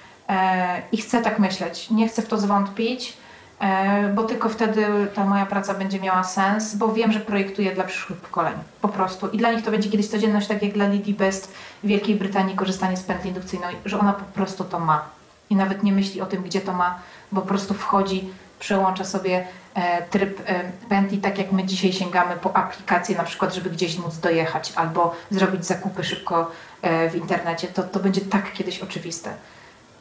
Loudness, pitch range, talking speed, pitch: -23 LUFS, 185-205 Hz, 190 wpm, 190 Hz